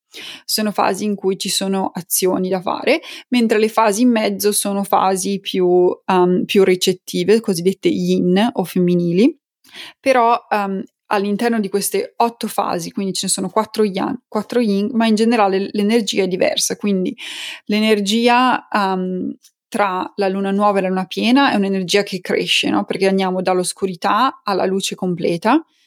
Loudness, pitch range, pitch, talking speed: -17 LUFS, 190-230 Hz, 205 Hz, 155 wpm